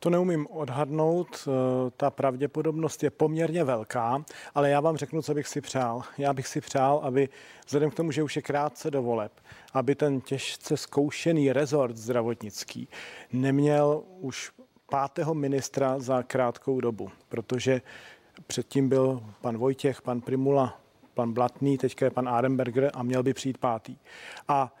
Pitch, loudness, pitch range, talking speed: 135 Hz, -28 LUFS, 125-150 Hz, 150 wpm